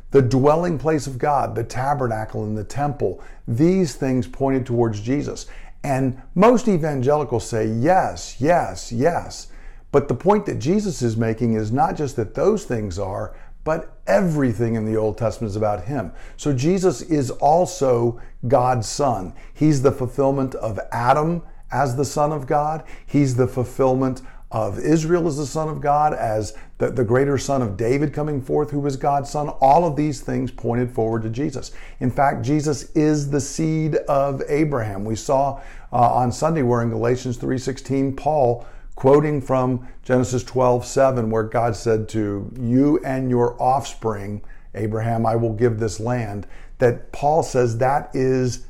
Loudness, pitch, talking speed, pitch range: -21 LUFS, 130 Hz, 165 wpm, 115-145 Hz